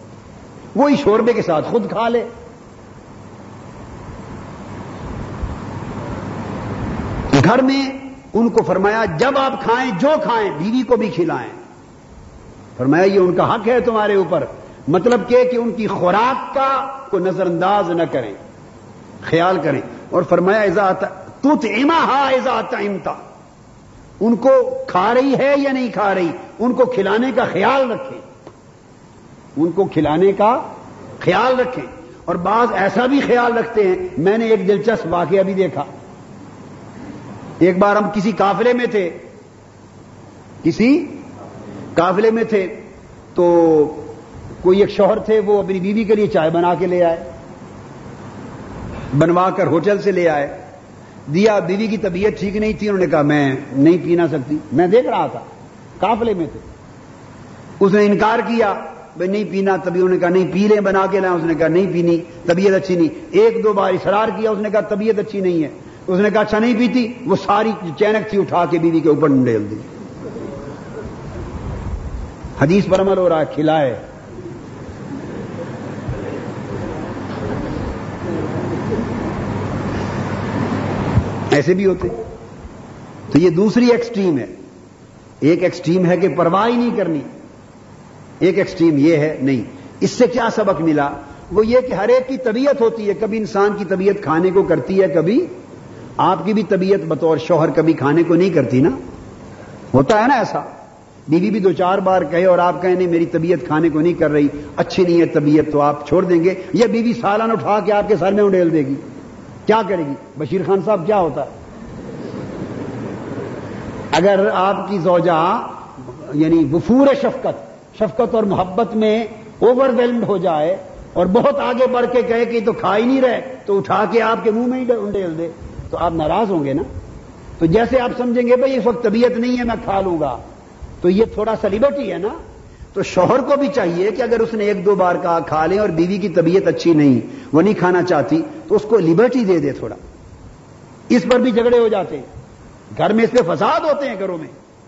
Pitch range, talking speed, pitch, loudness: 170-230 Hz, 170 wpm, 195 Hz, -16 LUFS